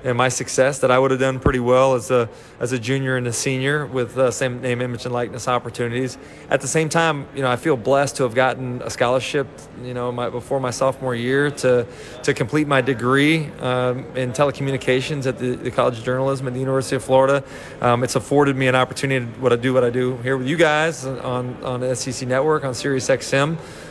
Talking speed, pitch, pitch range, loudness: 230 wpm, 130 Hz, 125-135 Hz, -20 LUFS